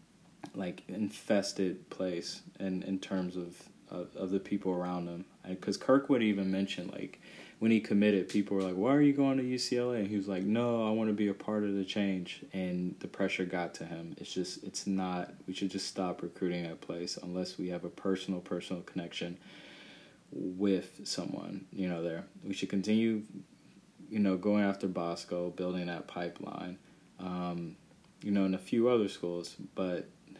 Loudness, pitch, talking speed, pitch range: -34 LUFS, 95 Hz, 190 wpm, 90-105 Hz